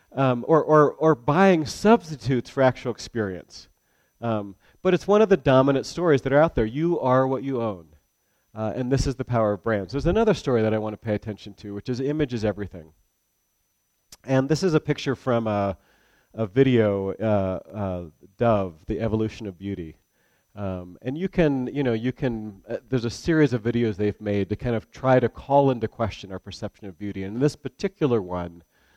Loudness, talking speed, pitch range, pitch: -23 LUFS, 205 wpm, 100-135 Hz, 115 Hz